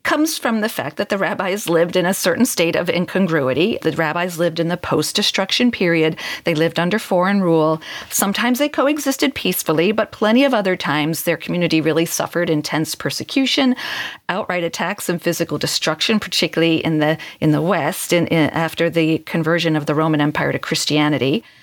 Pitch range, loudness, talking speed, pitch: 160-200 Hz, -18 LUFS, 180 wpm, 170 Hz